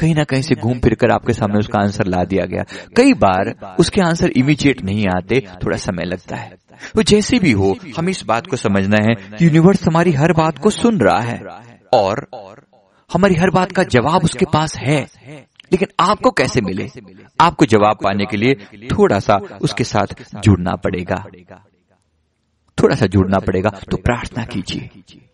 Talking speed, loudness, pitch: 175 wpm, -16 LUFS, 125 Hz